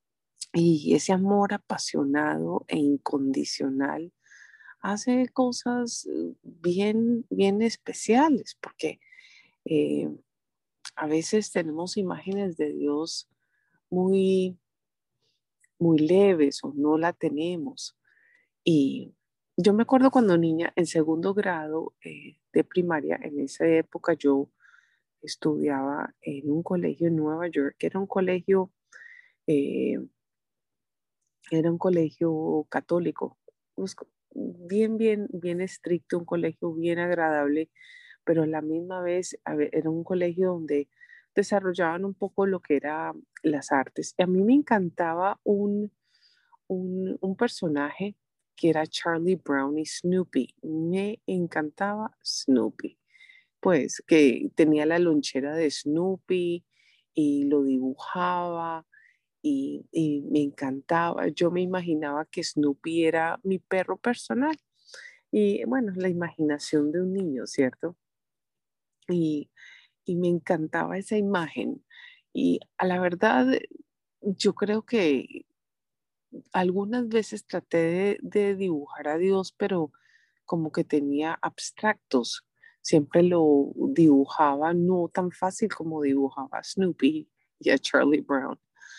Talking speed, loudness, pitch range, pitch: 115 wpm, -26 LUFS, 155-205 Hz, 175 Hz